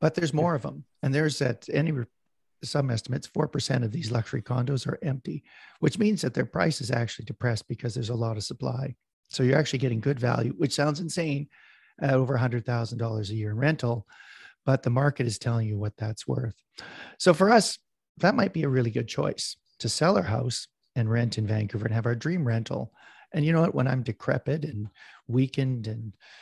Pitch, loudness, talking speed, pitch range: 130 Hz, -27 LUFS, 205 wpm, 115-150 Hz